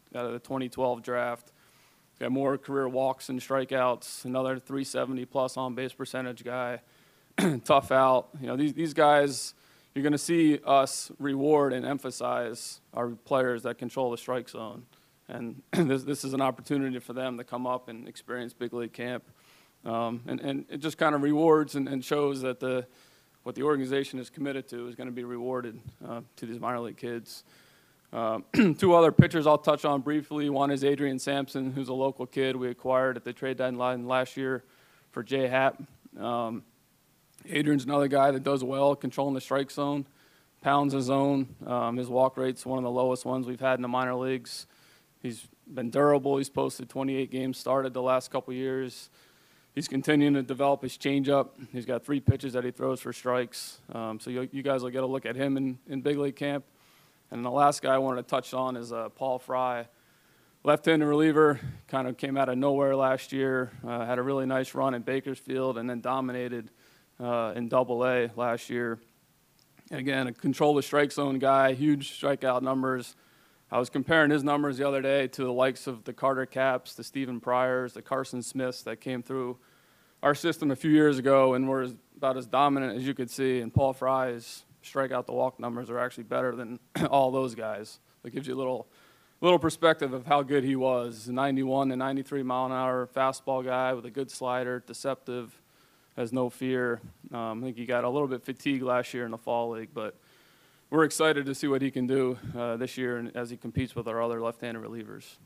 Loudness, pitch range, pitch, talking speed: -29 LUFS, 125-140 Hz, 130 Hz, 200 wpm